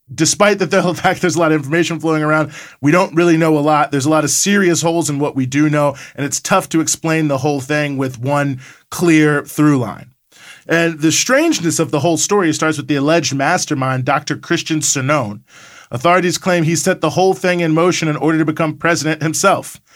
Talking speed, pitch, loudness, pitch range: 215 wpm, 160 Hz, -15 LUFS, 150-170 Hz